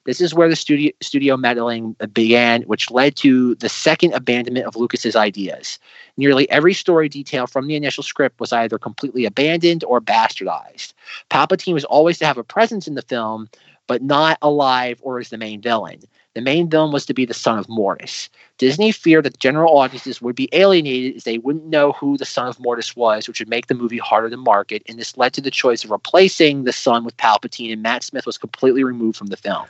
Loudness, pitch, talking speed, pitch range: -17 LUFS, 130 Hz, 215 wpm, 115-150 Hz